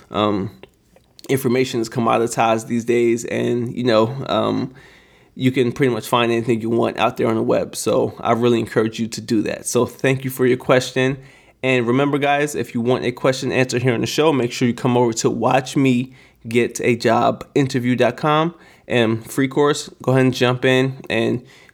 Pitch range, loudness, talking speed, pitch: 115-130 Hz, -19 LUFS, 195 wpm, 125 Hz